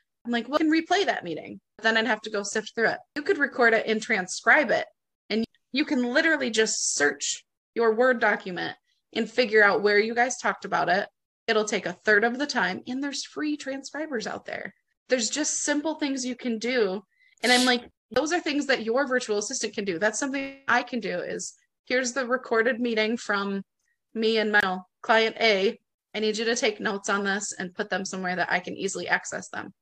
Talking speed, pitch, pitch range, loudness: 215 wpm, 235 Hz, 215-275 Hz, -25 LUFS